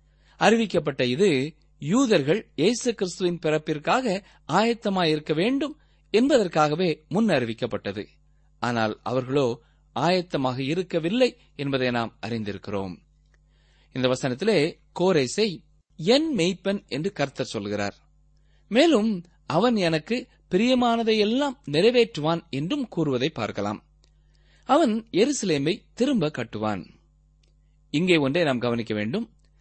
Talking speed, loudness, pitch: 85 wpm, -24 LUFS, 150 Hz